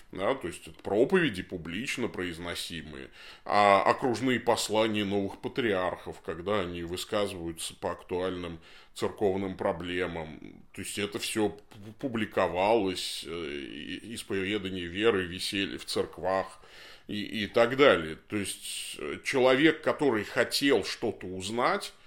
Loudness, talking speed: -29 LUFS, 110 wpm